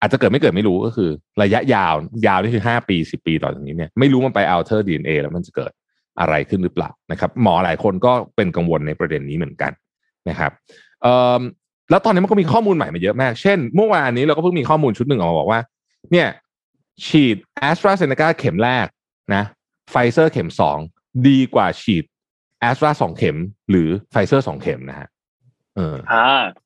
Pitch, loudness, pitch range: 125 Hz, -17 LUFS, 95-150 Hz